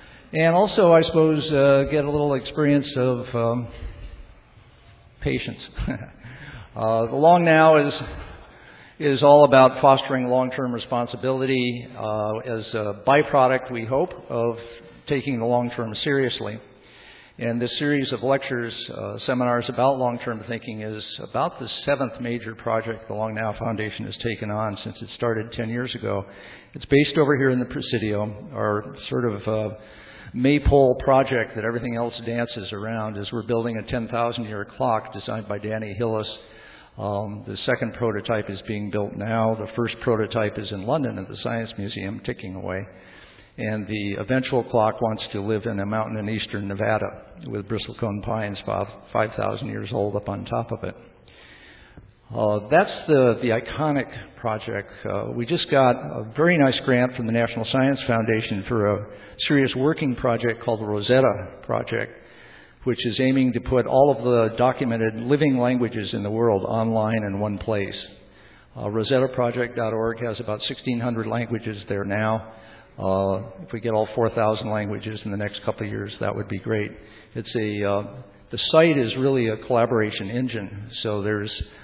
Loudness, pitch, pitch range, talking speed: -23 LUFS, 115 Hz, 105-125 Hz, 160 wpm